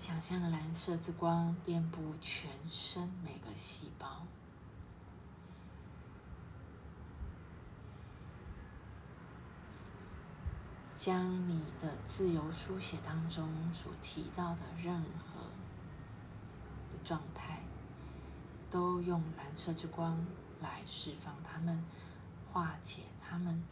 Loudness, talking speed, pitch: -41 LUFS, 120 characters per minute, 160 Hz